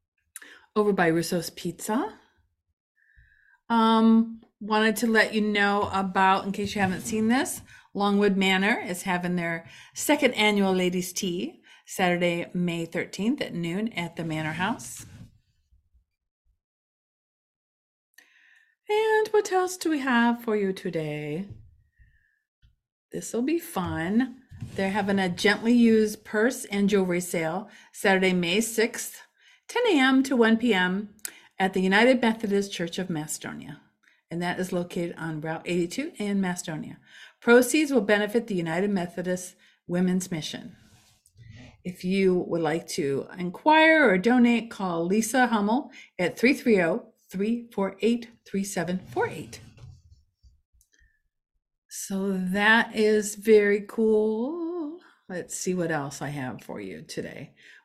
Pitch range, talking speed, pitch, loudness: 170-230 Hz, 120 wpm, 195 Hz, -25 LUFS